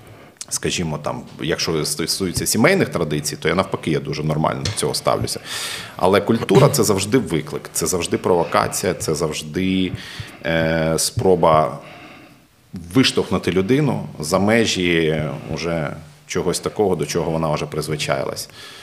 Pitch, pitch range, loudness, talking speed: 85 Hz, 80-95 Hz, -19 LUFS, 120 wpm